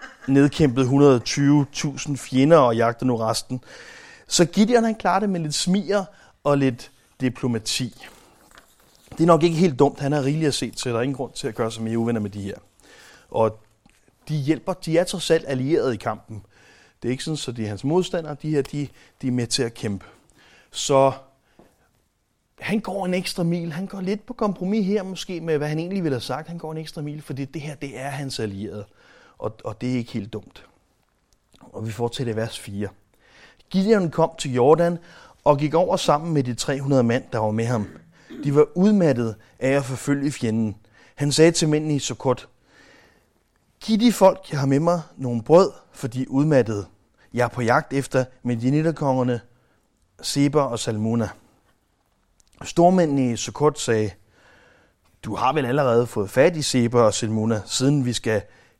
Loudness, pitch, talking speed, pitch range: -22 LUFS, 140 Hz, 190 wpm, 120-165 Hz